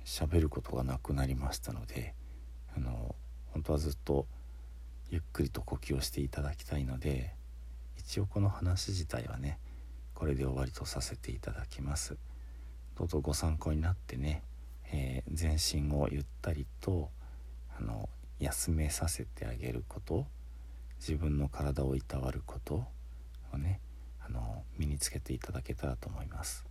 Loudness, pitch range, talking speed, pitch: -37 LUFS, 60-75 Hz, 290 characters per minute, 65 Hz